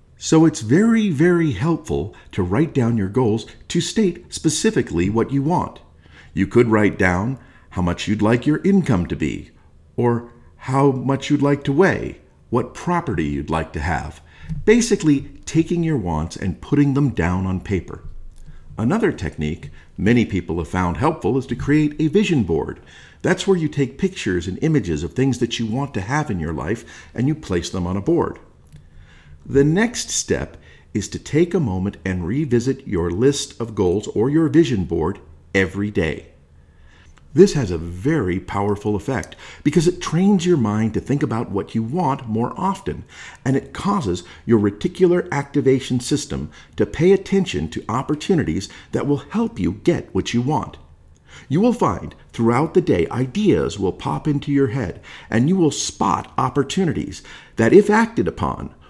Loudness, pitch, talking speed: -20 LUFS, 115 Hz, 170 wpm